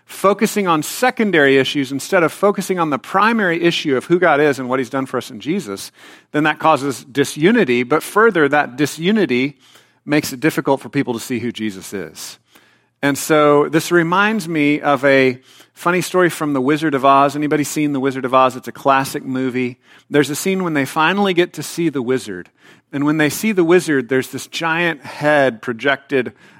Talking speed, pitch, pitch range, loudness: 195 wpm, 145 Hz, 130-165 Hz, -16 LUFS